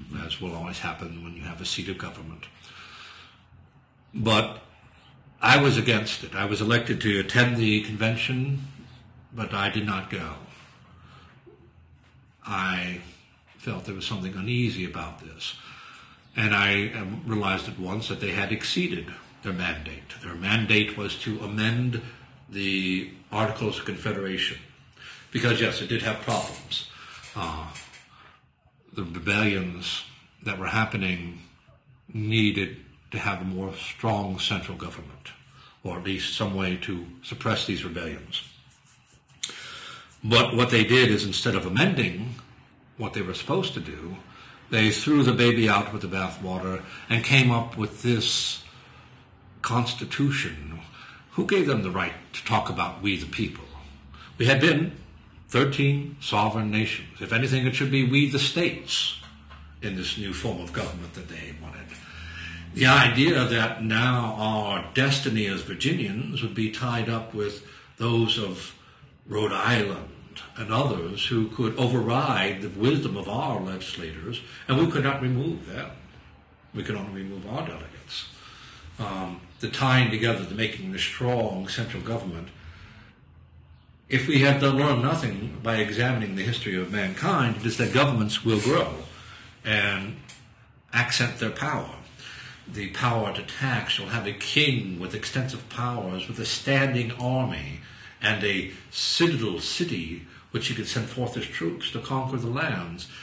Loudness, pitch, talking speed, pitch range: -26 LUFS, 105 Hz, 145 wpm, 95-120 Hz